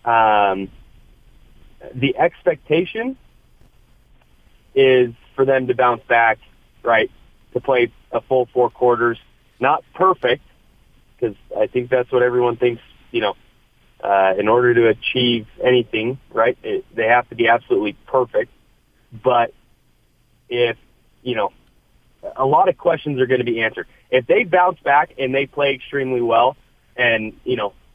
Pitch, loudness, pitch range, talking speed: 125 Hz, -18 LUFS, 115-140 Hz, 140 wpm